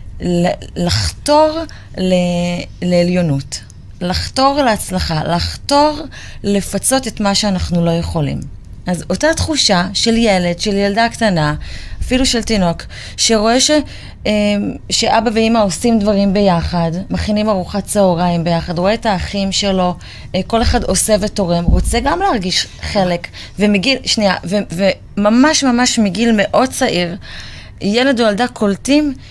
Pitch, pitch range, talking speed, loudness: 200 Hz, 175-230 Hz, 115 wpm, -14 LUFS